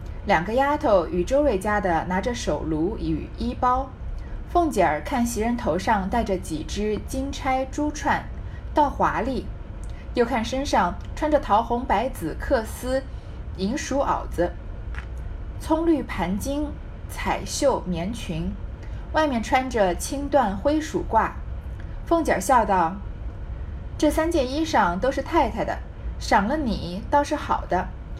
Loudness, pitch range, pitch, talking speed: -24 LUFS, 205-290 Hz, 260 Hz, 190 characters per minute